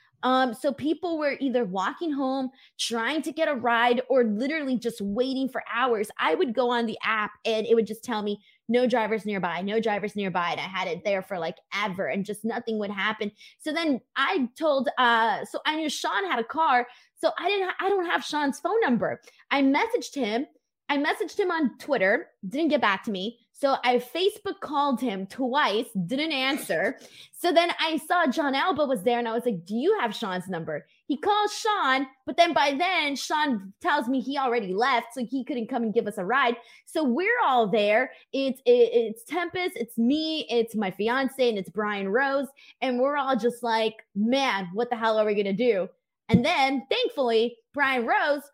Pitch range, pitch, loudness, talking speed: 225-295 Hz, 255 Hz, -26 LUFS, 205 wpm